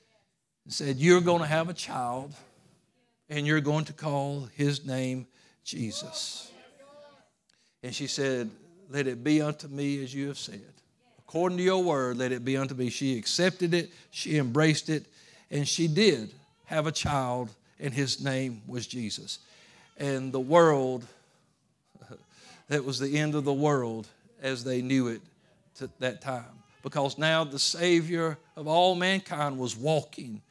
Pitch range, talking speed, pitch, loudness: 130-165 Hz, 155 wpm, 145 Hz, -29 LUFS